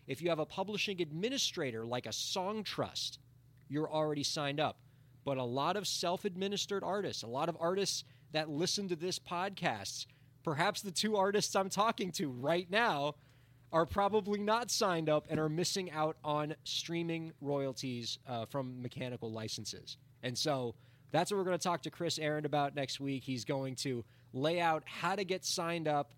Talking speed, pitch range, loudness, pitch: 180 wpm, 130-180 Hz, -36 LUFS, 155 Hz